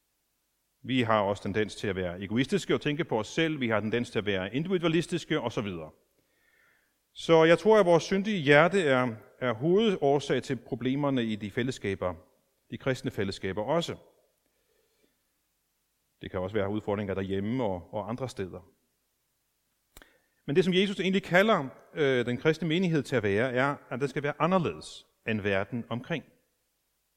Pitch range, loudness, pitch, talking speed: 110-165 Hz, -28 LUFS, 130 Hz, 160 wpm